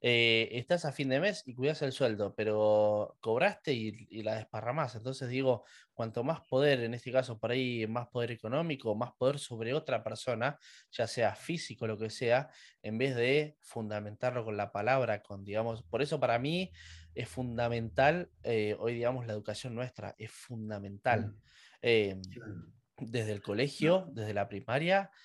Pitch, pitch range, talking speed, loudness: 120 Hz, 110-130 Hz, 165 wpm, -33 LUFS